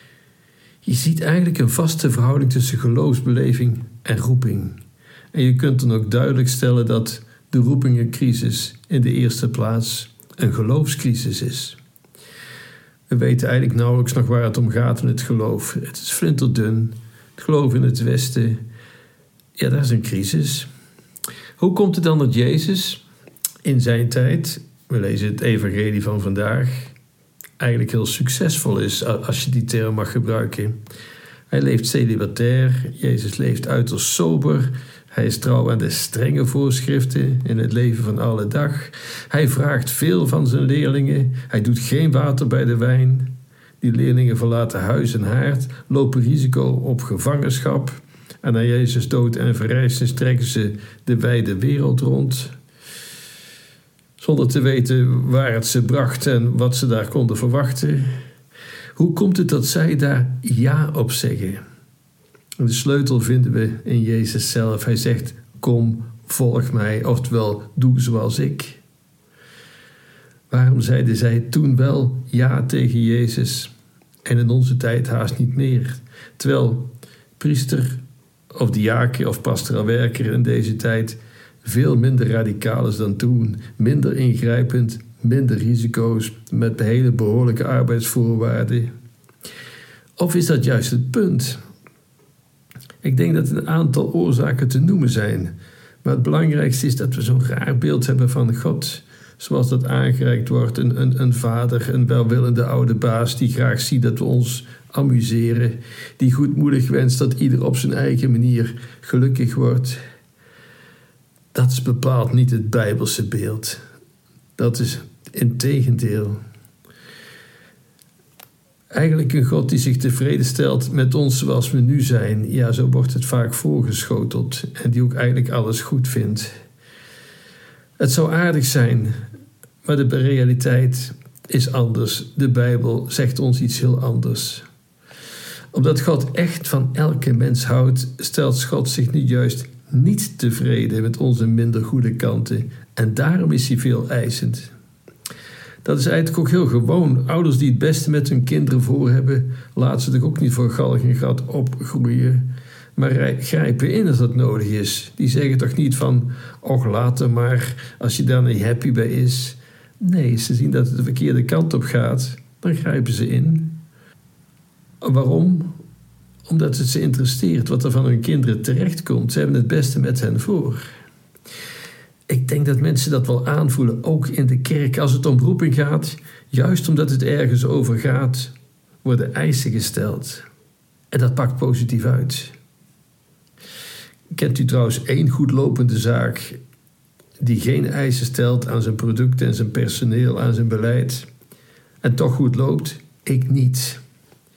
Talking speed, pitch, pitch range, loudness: 150 wpm, 125 Hz, 120-135 Hz, -18 LUFS